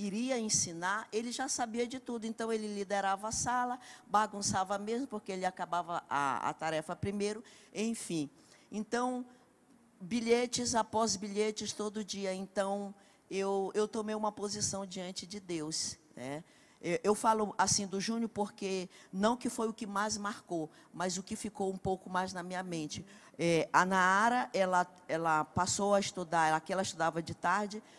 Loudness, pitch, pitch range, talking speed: -34 LUFS, 205 Hz, 185-225 Hz, 160 wpm